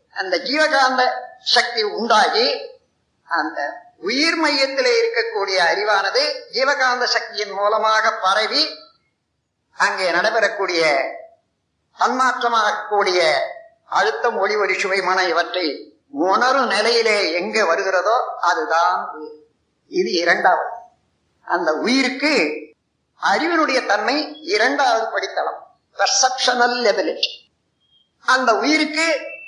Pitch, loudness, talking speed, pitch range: 270 Hz, -18 LUFS, 75 wpm, 230-355 Hz